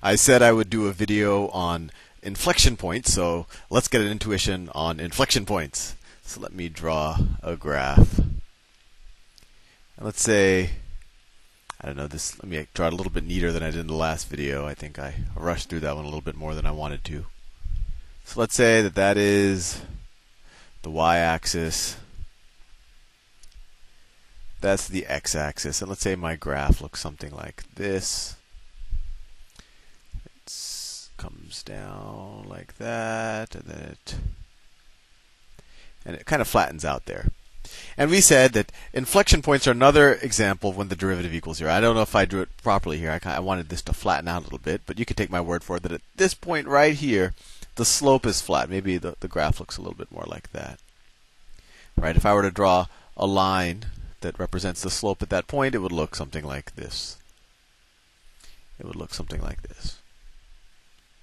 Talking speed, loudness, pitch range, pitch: 180 wpm, -23 LUFS, 80-100 Hz, 90 Hz